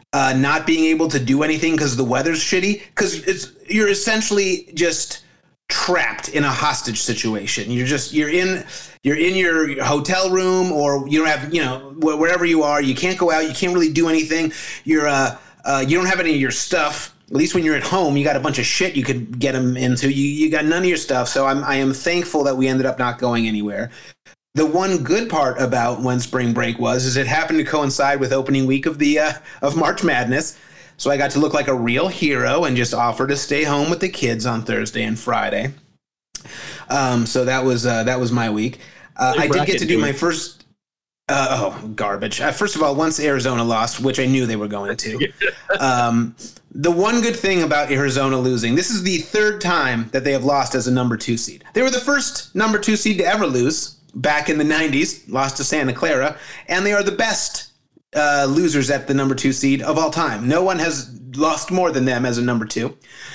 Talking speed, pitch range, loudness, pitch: 225 wpm, 130-165 Hz, -19 LUFS, 140 Hz